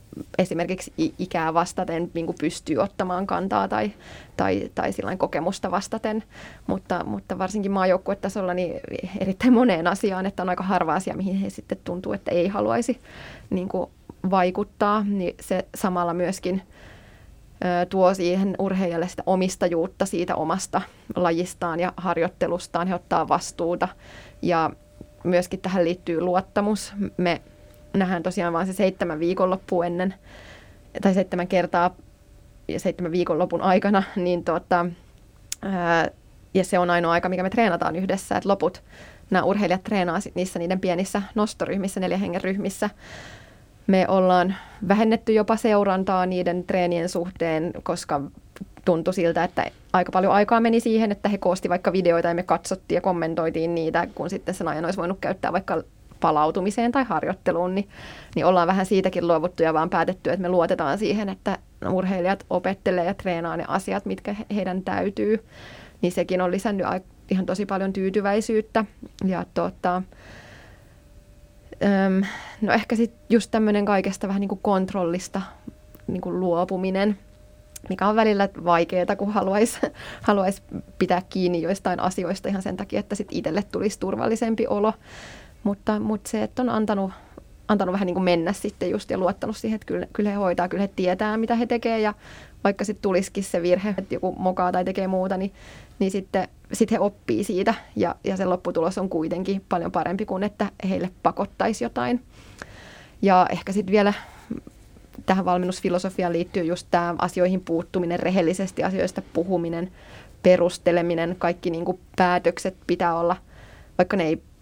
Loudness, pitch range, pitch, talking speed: -24 LUFS, 175-200 Hz, 185 Hz, 150 wpm